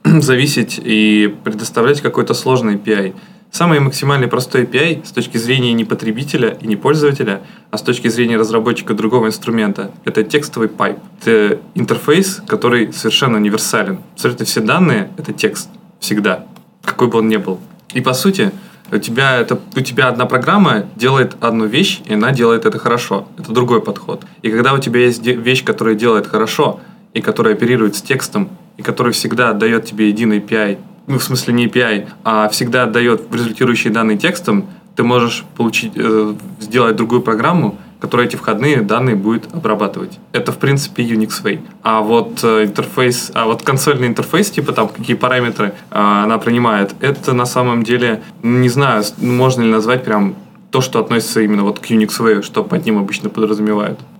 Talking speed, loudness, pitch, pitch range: 170 wpm, -14 LUFS, 115 Hz, 110-130 Hz